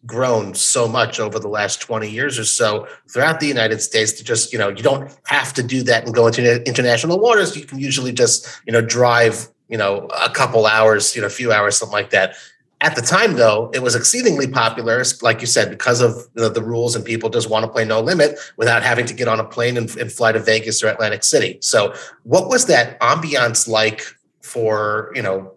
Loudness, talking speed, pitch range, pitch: -16 LUFS, 230 wpm, 110-130 Hz, 120 Hz